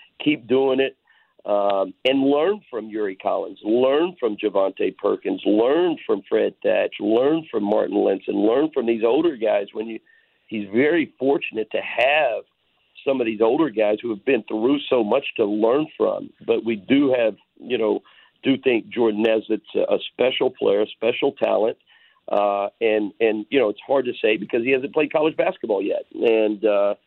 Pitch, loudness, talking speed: 130 Hz, -21 LUFS, 180 wpm